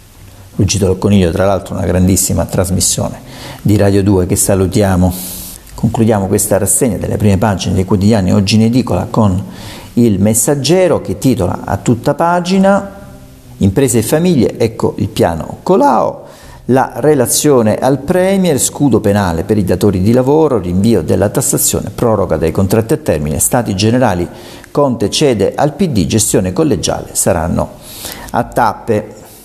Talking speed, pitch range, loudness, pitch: 140 wpm, 95-125 Hz, -12 LUFS, 105 Hz